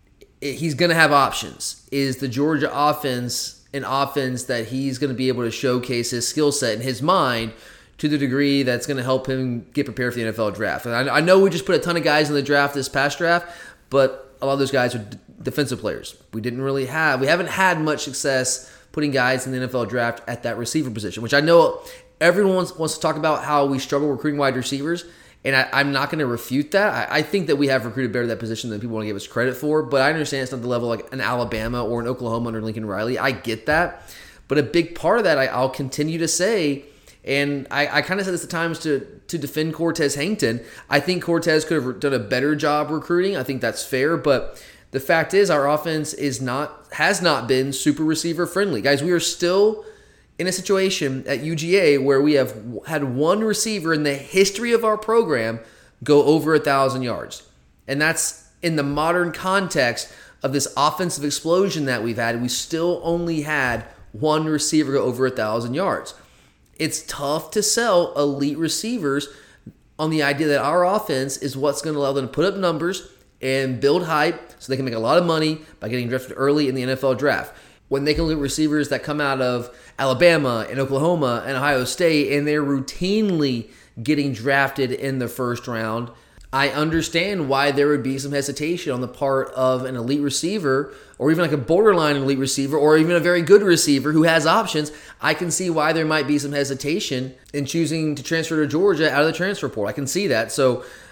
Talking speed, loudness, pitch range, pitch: 220 wpm, -21 LUFS, 130-160 Hz, 145 Hz